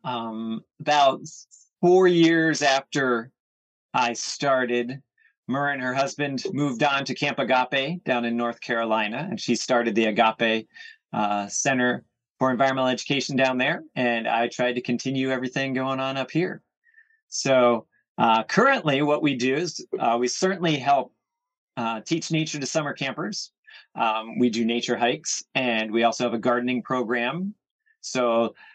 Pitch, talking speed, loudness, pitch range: 130 Hz, 150 wpm, -24 LUFS, 120-145 Hz